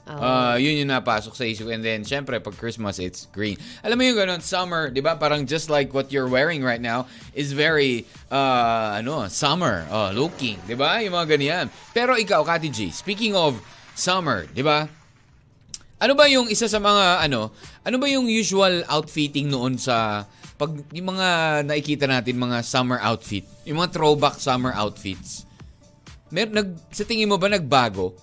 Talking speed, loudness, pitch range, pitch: 175 wpm, -22 LUFS, 120-175 Hz, 145 Hz